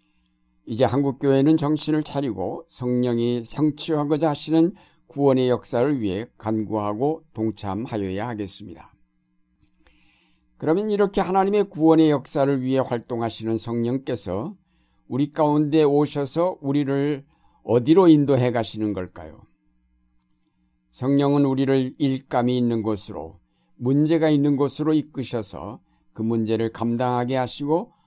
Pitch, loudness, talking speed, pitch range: 130 Hz, -22 LUFS, 285 characters per minute, 110-150 Hz